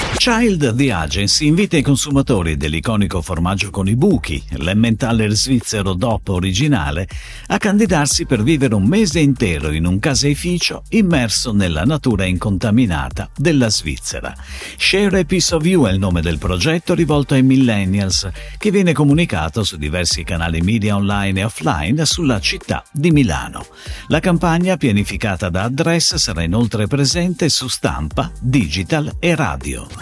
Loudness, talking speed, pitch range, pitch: -16 LUFS, 140 wpm, 95-150 Hz, 115 Hz